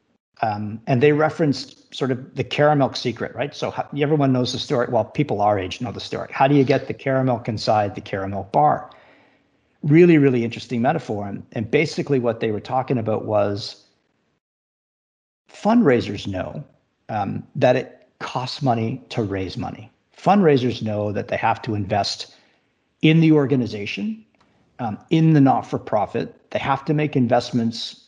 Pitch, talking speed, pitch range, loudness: 125 Hz, 165 wpm, 105-145 Hz, -21 LUFS